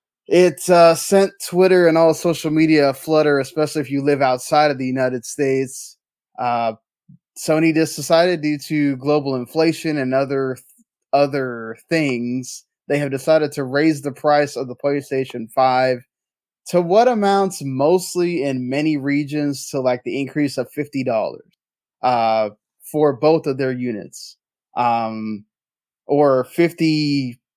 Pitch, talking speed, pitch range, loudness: 145 Hz, 145 wpm, 130-160 Hz, -18 LUFS